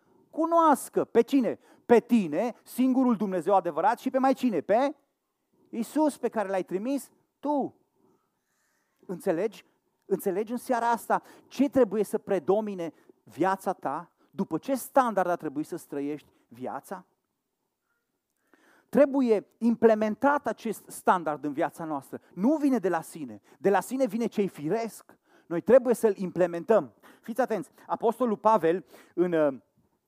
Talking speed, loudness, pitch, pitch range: 130 wpm, -27 LUFS, 220 Hz, 180-255 Hz